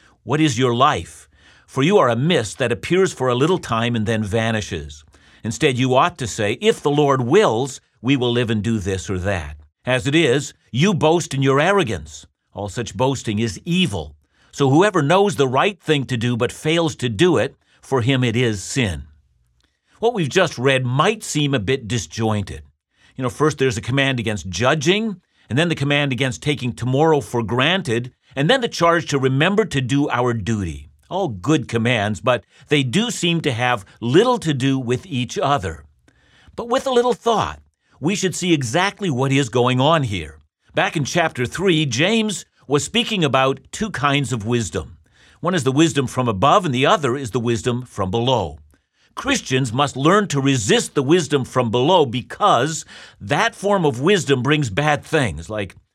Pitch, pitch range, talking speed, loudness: 130 Hz, 115-155 Hz, 190 wpm, -19 LUFS